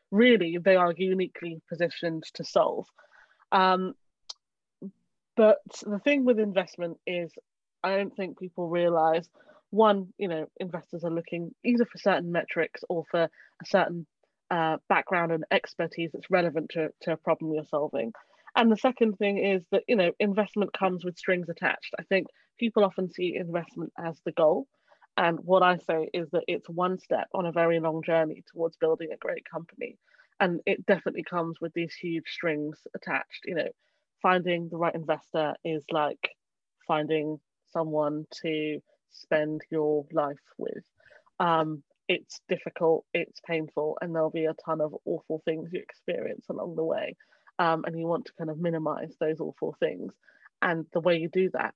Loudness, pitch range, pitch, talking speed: -28 LUFS, 160-190 Hz, 170 Hz, 170 wpm